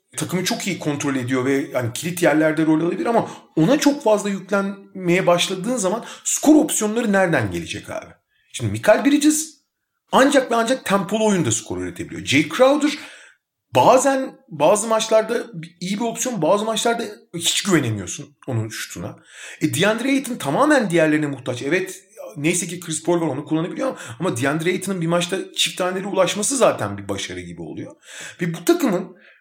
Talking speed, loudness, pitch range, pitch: 160 wpm, -20 LUFS, 155-230 Hz, 185 Hz